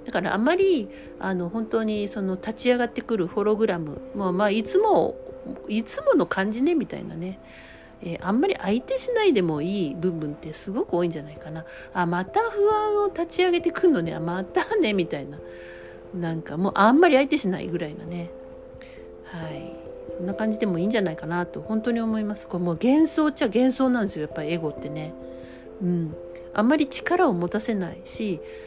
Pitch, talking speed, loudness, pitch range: 195 Hz, 385 characters per minute, -24 LUFS, 170-260 Hz